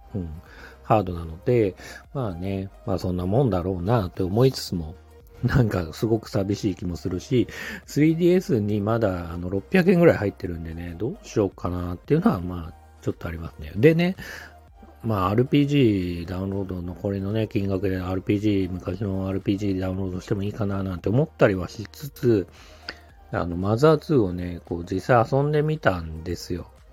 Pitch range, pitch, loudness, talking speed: 90-115 Hz, 95 Hz, -24 LUFS, 355 characters per minute